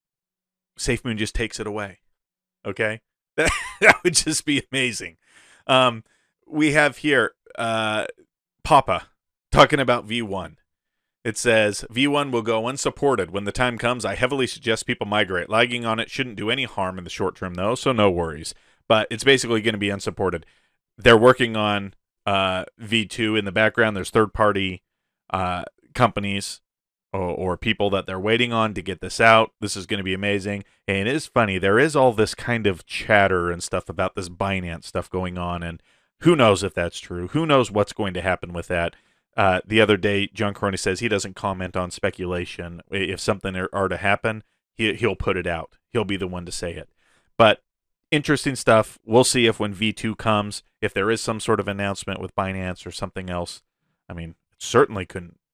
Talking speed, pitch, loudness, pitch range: 190 wpm, 105 Hz, -22 LUFS, 95-120 Hz